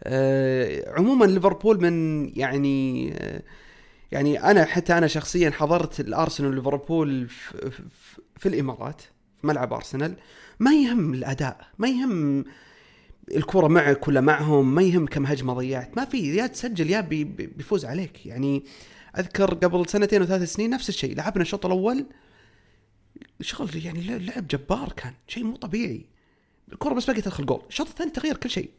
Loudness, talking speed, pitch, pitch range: -24 LUFS, 150 wpm, 170 Hz, 140-210 Hz